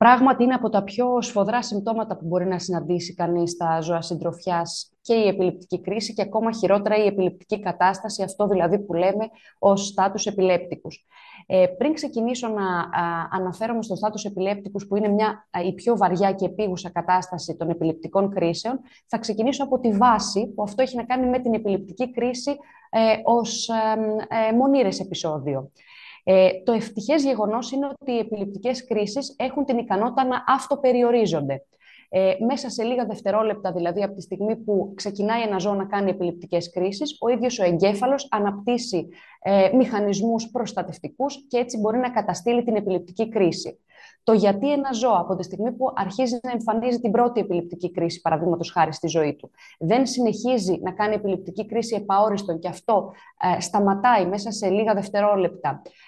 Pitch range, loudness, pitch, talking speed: 185-235 Hz, -23 LUFS, 205 Hz, 160 wpm